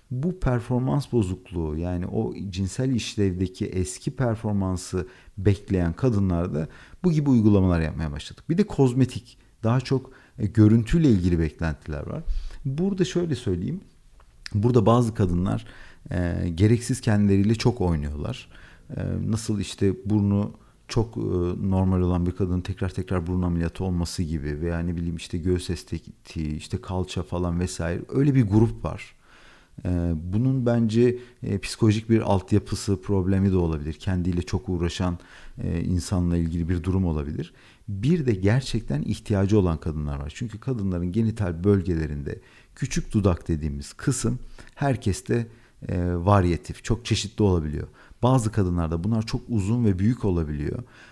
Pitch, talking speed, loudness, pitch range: 95 Hz, 135 wpm, -25 LUFS, 85-115 Hz